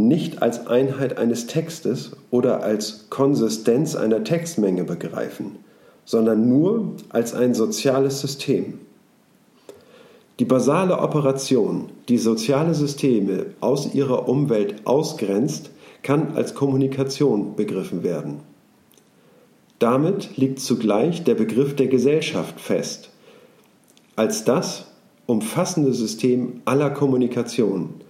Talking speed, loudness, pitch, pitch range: 100 wpm, -21 LUFS, 130 Hz, 115-140 Hz